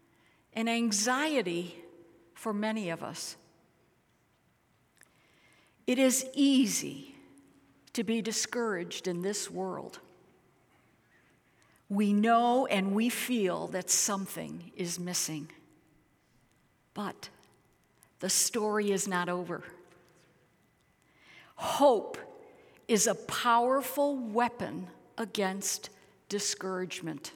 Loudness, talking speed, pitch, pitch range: -30 LUFS, 80 wpm, 200 Hz, 180-235 Hz